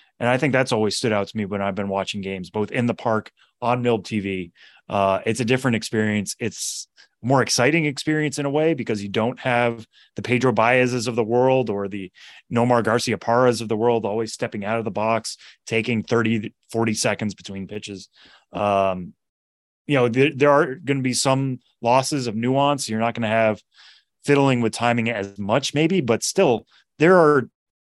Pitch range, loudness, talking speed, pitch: 105-125 Hz, -21 LUFS, 190 wpm, 115 Hz